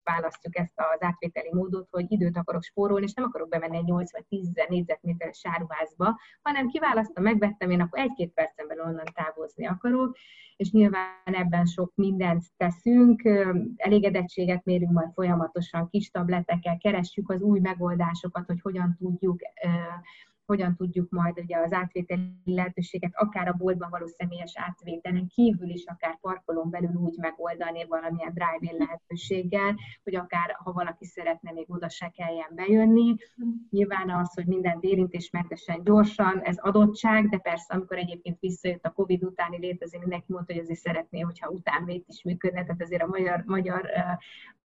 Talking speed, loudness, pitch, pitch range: 150 wpm, -27 LUFS, 180 Hz, 170-195 Hz